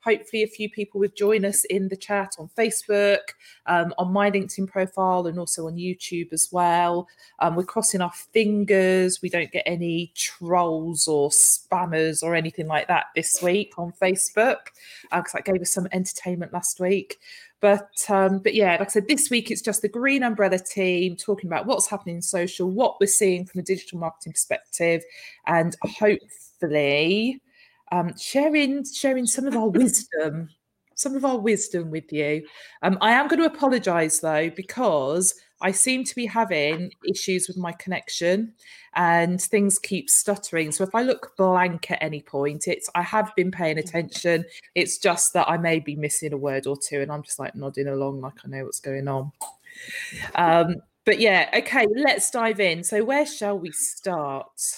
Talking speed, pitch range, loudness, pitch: 180 wpm, 170-210 Hz, -23 LUFS, 185 Hz